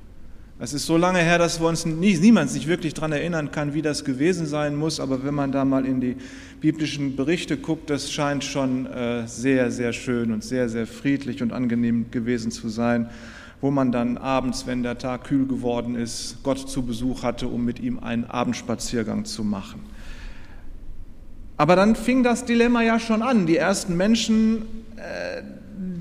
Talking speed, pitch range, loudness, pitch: 180 wpm, 120-165 Hz, -23 LUFS, 135 Hz